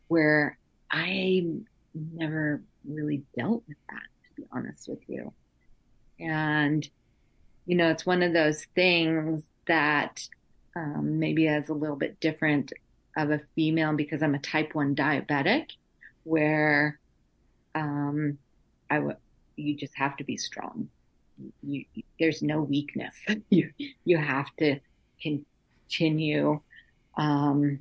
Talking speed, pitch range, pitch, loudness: 125 wpm, 145-160 Hz, 150 Hz, -28 LUFS